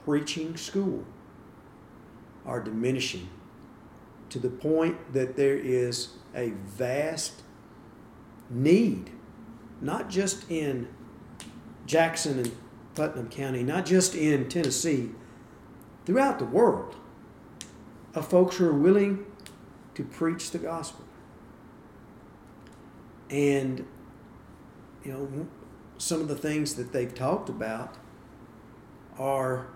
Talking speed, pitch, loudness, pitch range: 95 wpm, 135 Hz, -28 LUFS, 125-165 Hz